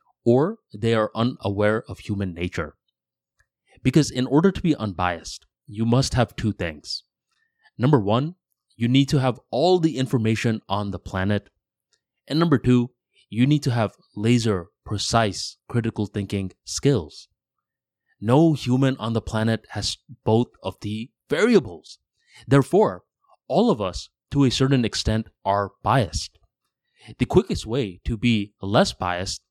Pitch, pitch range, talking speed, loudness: 115 Hz, 100-130 Hz, 140 wpm, -23 LUFS